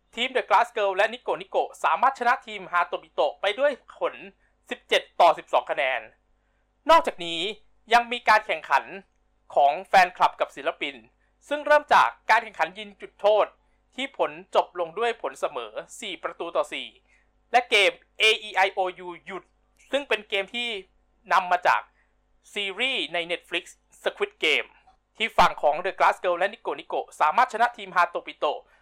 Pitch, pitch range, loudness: 220 Hz, 190-255 Hz, -24 LUFS